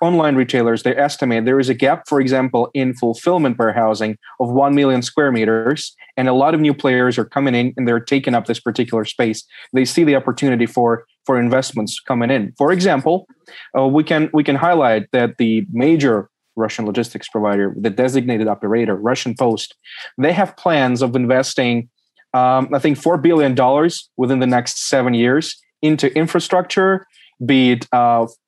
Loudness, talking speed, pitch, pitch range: -16 LUFS, 175 wpm, 130 Hz, 120-140 Hz